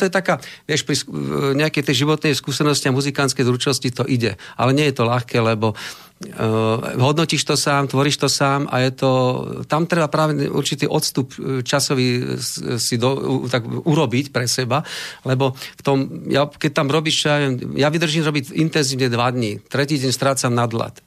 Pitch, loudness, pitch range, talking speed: 140 Hz, -19 LUFS, 125-150 Hz, 170 wpm